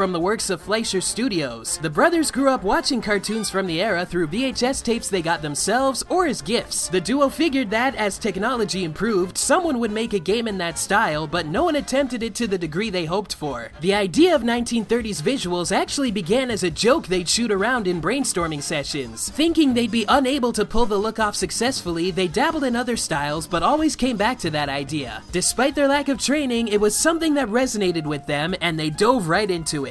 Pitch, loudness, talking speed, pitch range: 215 Hz, -21 LUFS, 215 wpm, 180-255 Hz